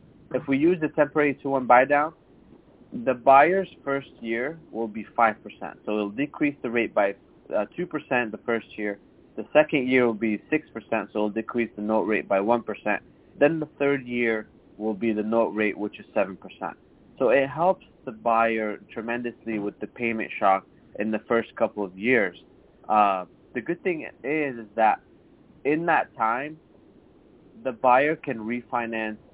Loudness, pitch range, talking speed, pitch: -25 LUFS, 110-140 Hz, 170 wpm, 120 Hz